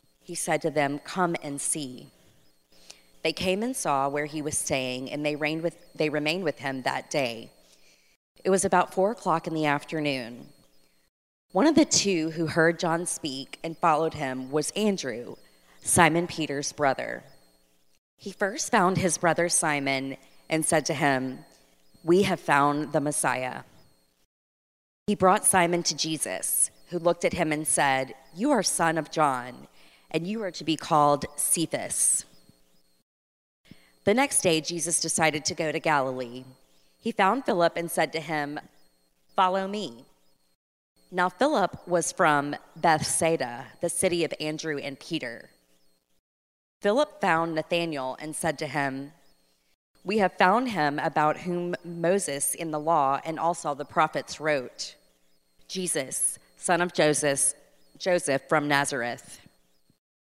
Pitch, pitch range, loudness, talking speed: 155 Hz, 130-170 Hz, -26 LUFS, 145 wpm